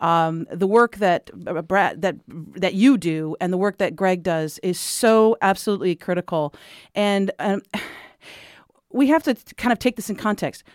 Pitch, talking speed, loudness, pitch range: 195 Hz, 175 wpm, -21 LUFS, 175-215 Hz